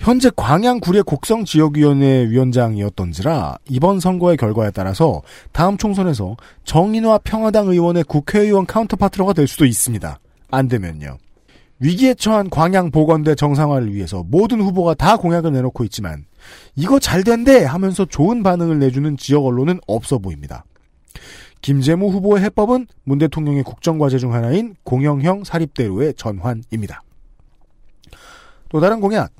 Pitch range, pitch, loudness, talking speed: 125-195 Hz, 155 Hz, -16 LUFS, 345 characters per minute